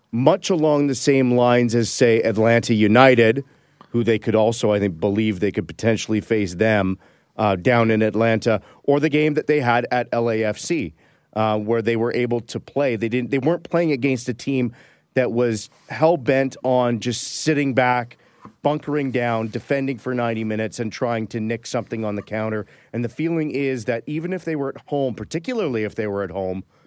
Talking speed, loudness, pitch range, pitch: 195 wpm, -21 LUFS, 110-140 Hz, 120 Hz